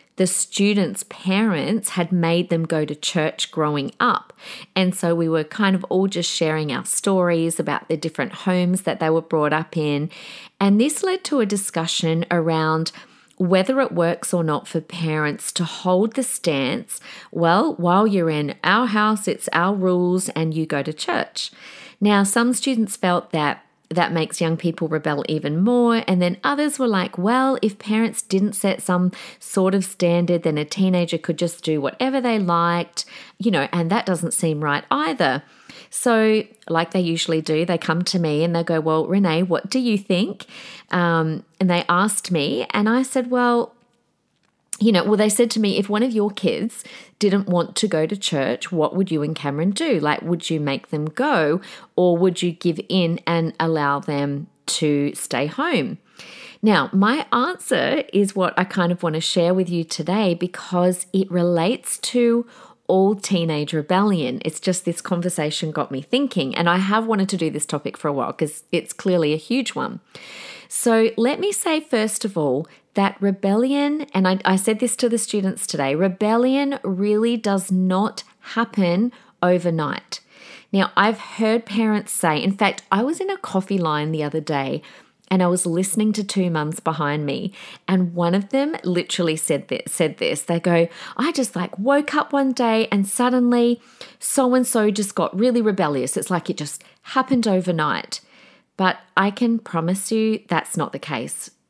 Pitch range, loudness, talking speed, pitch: 165-220 Hz, -20 LUFS, 185 wpm, 185 Hz